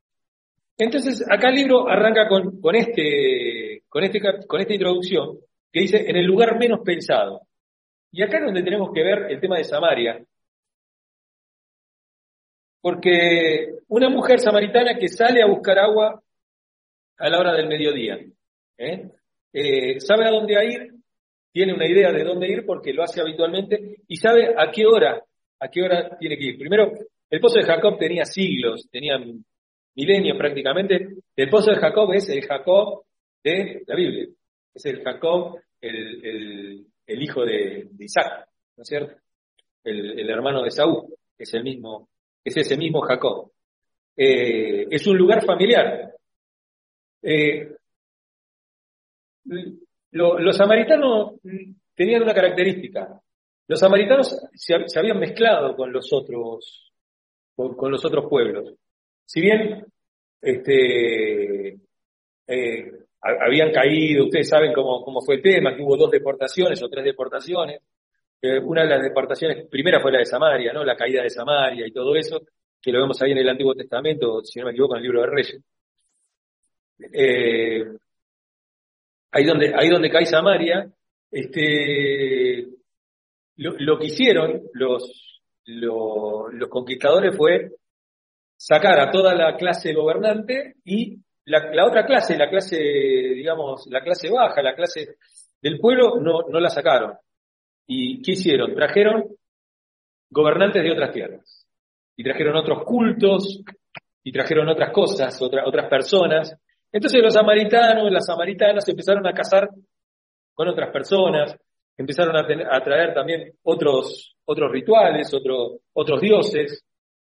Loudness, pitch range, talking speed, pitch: -19 LUFS, 150-230 Hz, 145 wpm, 190 Hz